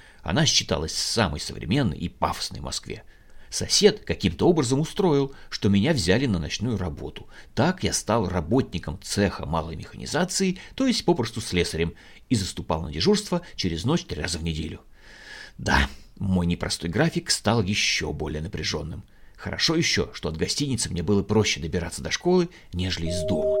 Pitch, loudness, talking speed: 100 Hz, -25 LUFS, 155 wpm